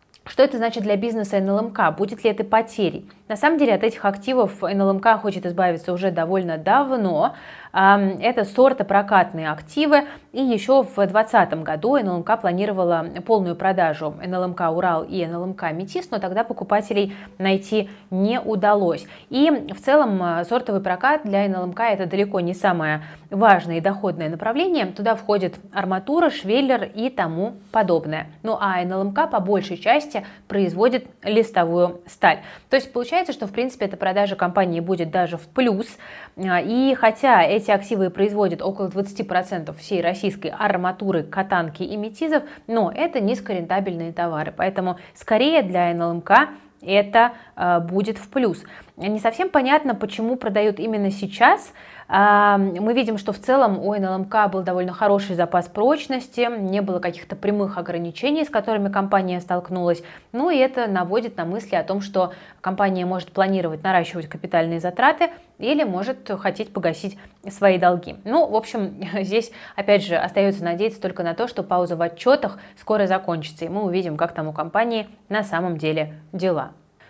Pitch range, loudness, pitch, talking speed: 180-225 Hz, -21 LUFS, 200 Hz, 150 wpm